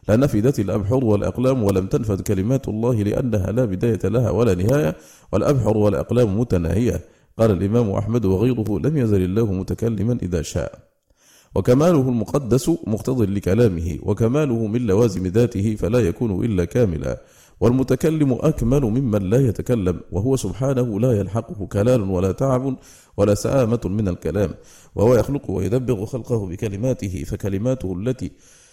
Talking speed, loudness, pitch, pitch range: 125 wpm, -20 LUFS, 115 Hz, 100-125 Hz